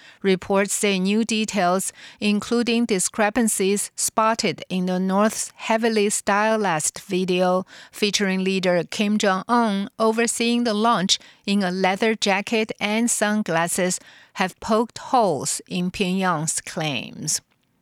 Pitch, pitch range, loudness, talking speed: 205 Hz, 185-225 Hz, -21 LUFS, 110 wpm